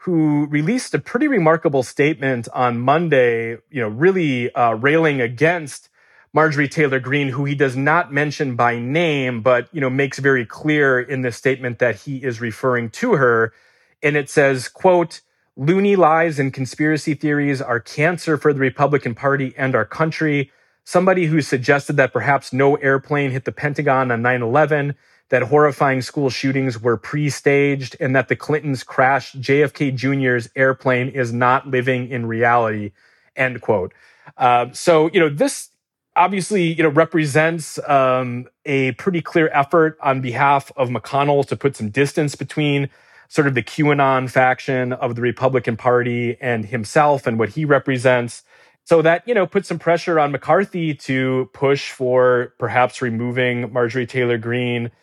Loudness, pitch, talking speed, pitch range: -18 LUFS, 135 Hz, 160 wpm, 125-150 Hz